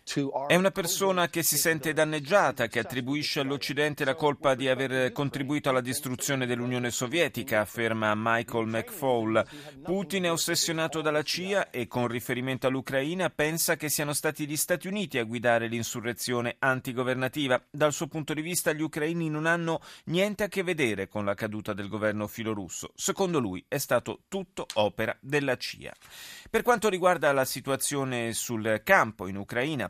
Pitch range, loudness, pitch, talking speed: 120-160 Hz, -28 LUFS, 140 Hz, 155 wpm